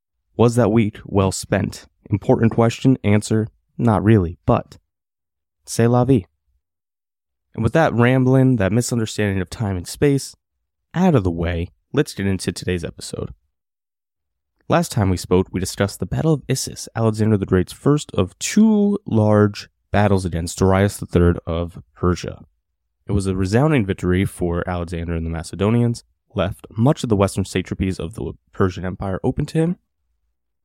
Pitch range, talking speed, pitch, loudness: 85-115 Hz, 155 wpm, 100 Hz, -19 LUFS